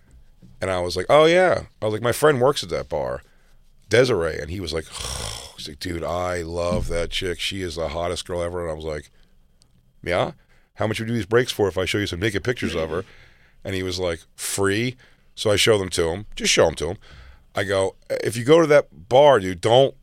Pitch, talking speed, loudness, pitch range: 95 Hz, 250 wpm, -22 LUFS, 80-115 Hz